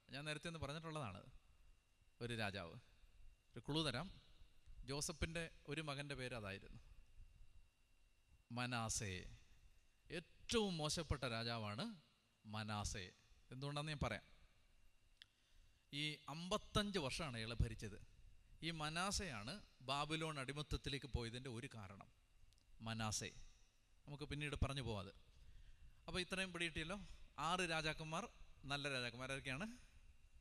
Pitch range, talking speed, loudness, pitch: 100-150 Hz, 90 wpm, -46 LUFS, 120 Hz